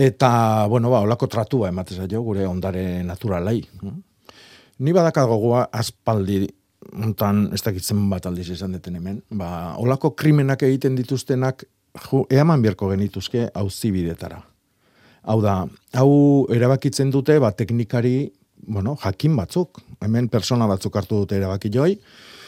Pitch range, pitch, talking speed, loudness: 100-130 Hz, 115 Hz, 135 wpm, -21 LUFS